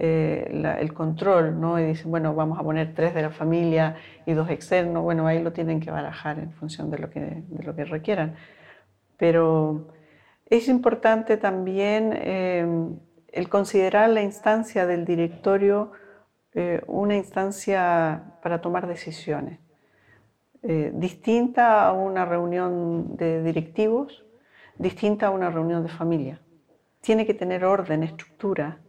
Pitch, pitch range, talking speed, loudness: 170 Hz, 160-195 Hz, 140 wpm, -24 LUFS